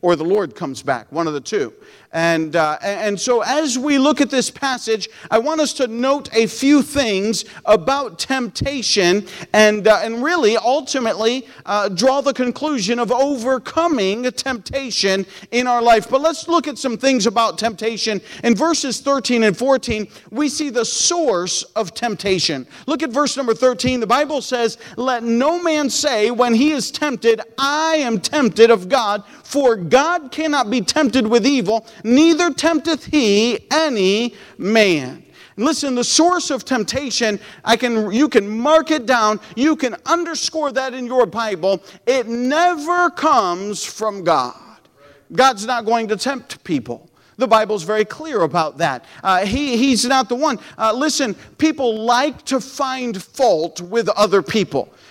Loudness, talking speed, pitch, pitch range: -17 LUFS, 160 wpm, 245 Hz, 215-280 Hz